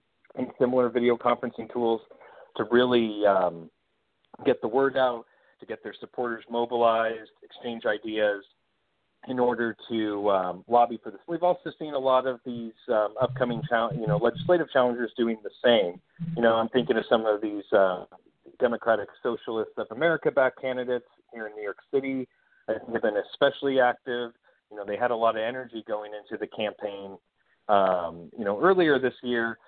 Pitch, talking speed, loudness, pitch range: 120 Hz, 175 wpm, -26 LUFS, 110-130 Hz